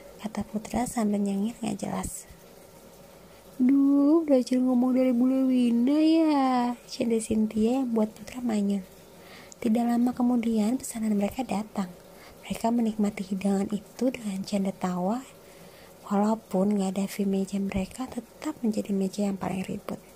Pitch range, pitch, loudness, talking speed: 195-245 Hz, 215 Hz, -27 LUFS, 125 wpm